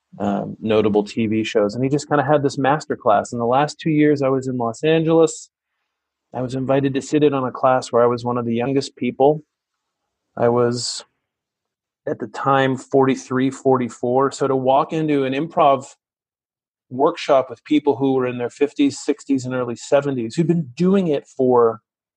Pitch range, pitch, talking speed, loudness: 120-145 Hz, 135 Hz, 185 wpm, -19 LUFS